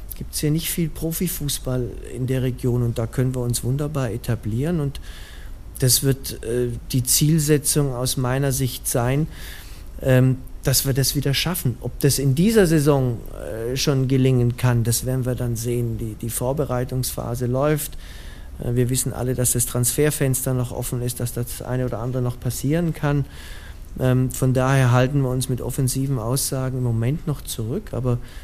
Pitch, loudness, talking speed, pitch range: 125 Hz, -22 LUFS, 160 wpm, 120-135 Hz